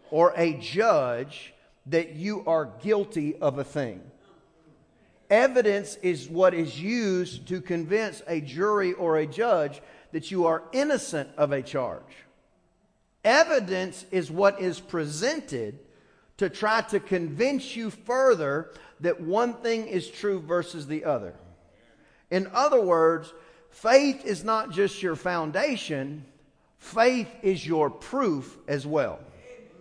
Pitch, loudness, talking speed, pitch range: 180 Hz, -26 LUFS, 125 wpm, 160-215 Hz